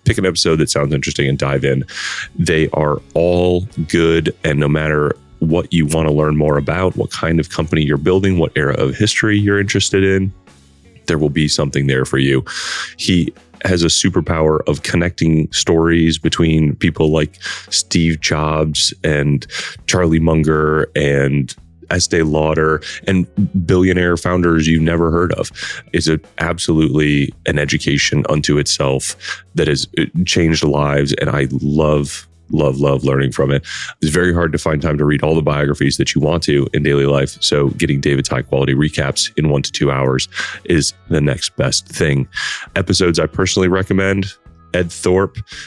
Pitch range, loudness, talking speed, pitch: 75-85 Hz, -15 LUFS, 165 wpm, 80 Hz